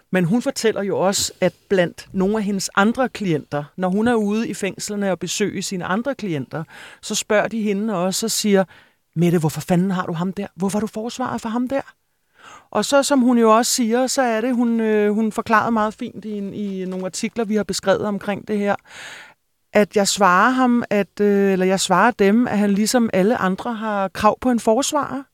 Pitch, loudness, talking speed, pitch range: 210 Hz, -19 LUFS, 210 wpm, 190-235 Hz